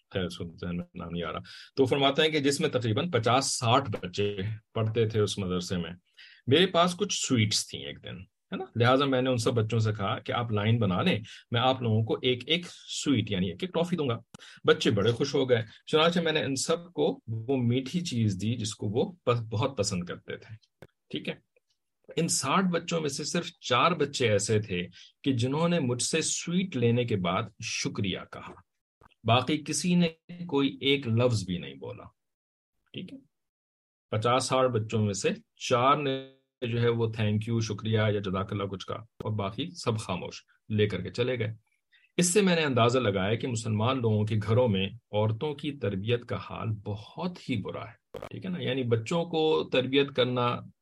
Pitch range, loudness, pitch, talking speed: 105-145 Hz, -28 LUFS, 120 Hz, 195 wpm